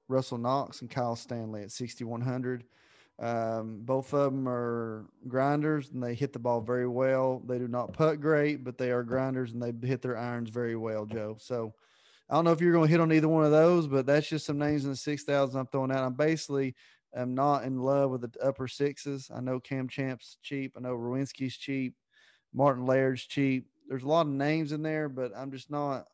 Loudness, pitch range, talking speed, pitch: -30 LUFS, 125-140 Hz, 220 wpm, 130 Hz